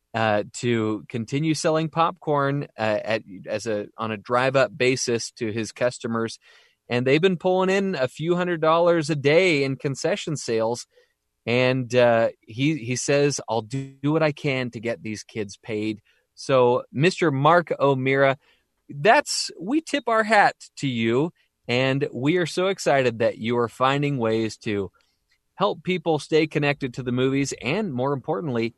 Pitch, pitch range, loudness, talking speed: 135 Hz, 115-160 Hz, -23 LUFS, 165 wpm